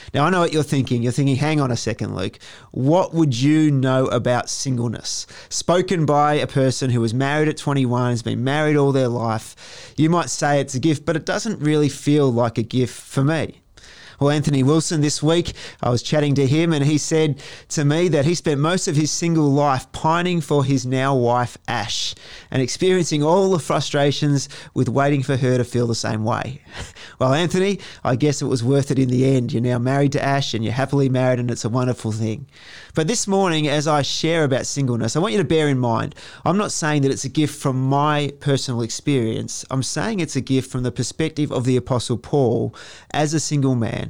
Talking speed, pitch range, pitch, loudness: 220 wpm, 125-150 Hz, 140 Hz, -20 LUFS